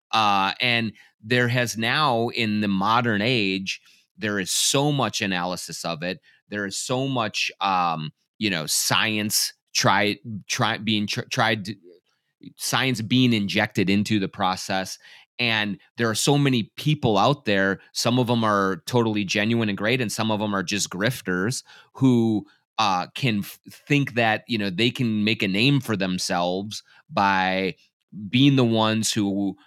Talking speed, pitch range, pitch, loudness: 160 wpm, 100-125 Hz, 110 Hz, -23 LUFS